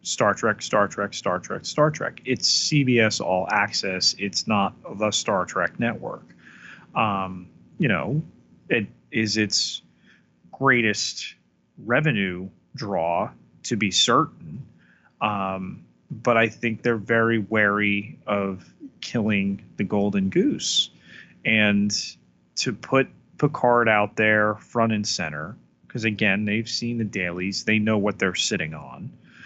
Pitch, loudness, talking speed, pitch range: 105 Hz, -23 LUFS, 130 wpm, 95-115 Hz